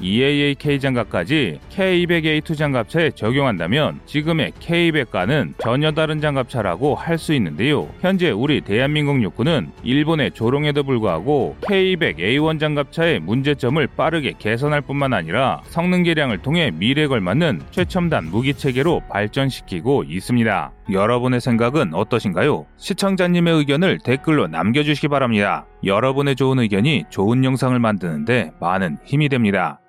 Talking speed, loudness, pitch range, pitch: 340 characters per minute, -19 LUFS, 125-160 Hz, 145 Hz